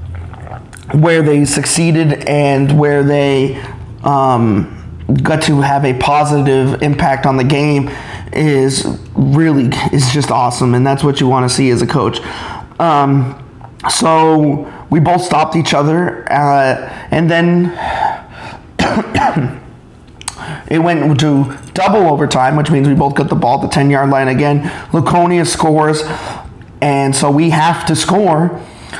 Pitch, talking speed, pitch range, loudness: 145 Hz, 140 wpm, 135-155 Hz, -12 LUFS